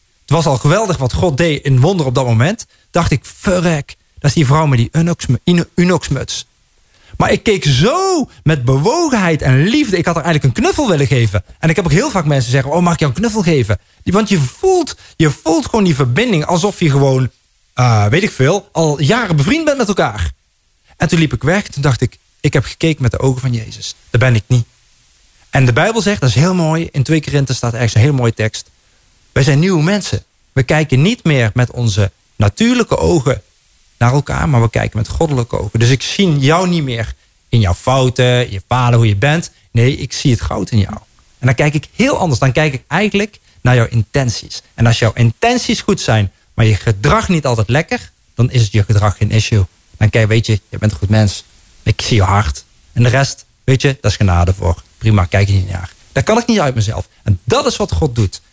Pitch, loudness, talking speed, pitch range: 130 Hz, -14 LUFS, 230 wpm, 110-165 Hz